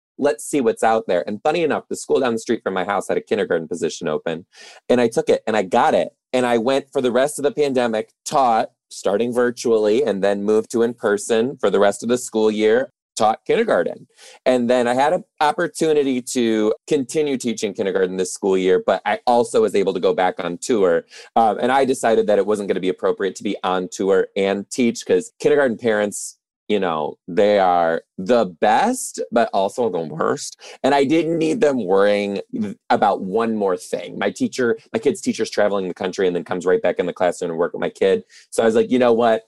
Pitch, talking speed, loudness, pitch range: 125 Hz, 225 wpm, -19 LUFS, 110-165 Hz